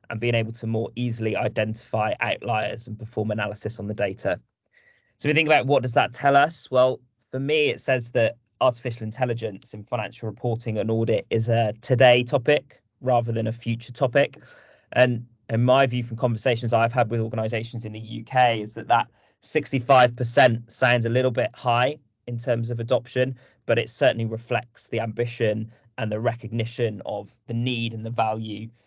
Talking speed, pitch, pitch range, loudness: 180 wpm, 115 Hz, 110-125 Hz, -24 LUFS